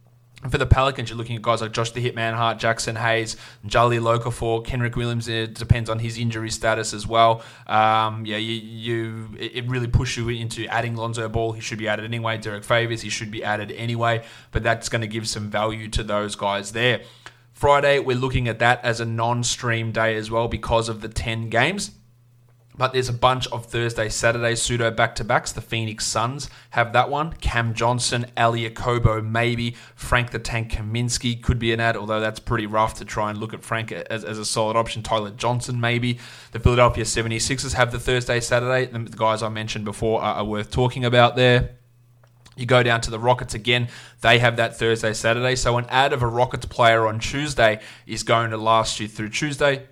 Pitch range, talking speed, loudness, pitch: 110-120 Hz, 200 wpm, -22 LUFS, 115 Hz